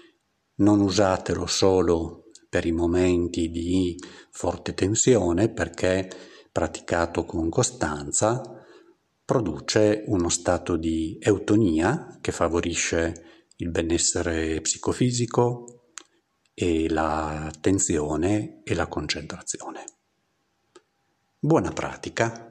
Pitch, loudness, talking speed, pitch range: 85 Hz, -24 LUFS, 85 wpm, 85-105 Hz